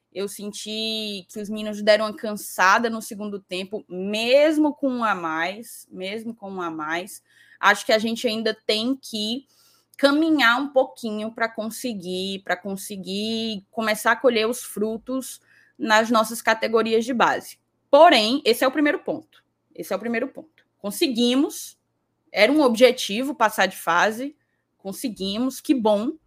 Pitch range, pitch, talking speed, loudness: 205-260 Hz, 225 Hz, 150 wpm, -22 LUFS